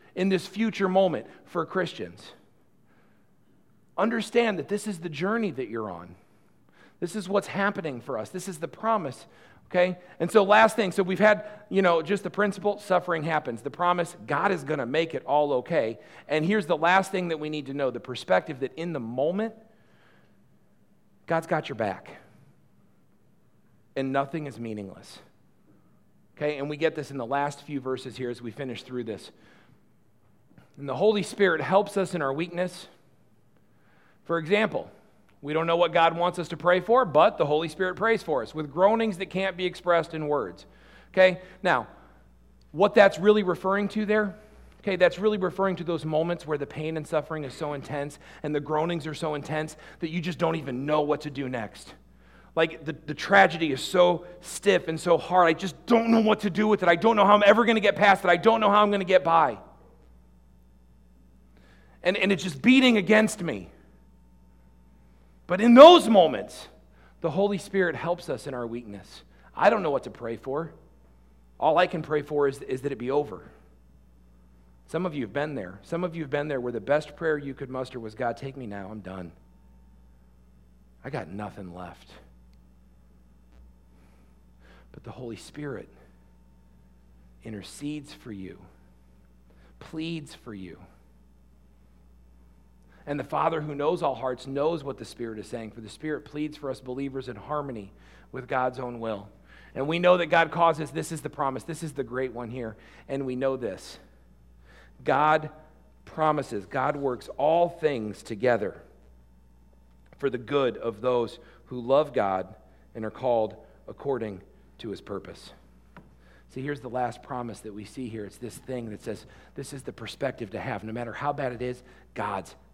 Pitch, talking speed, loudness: 140 Hz, 185 wpm, -26 LUFS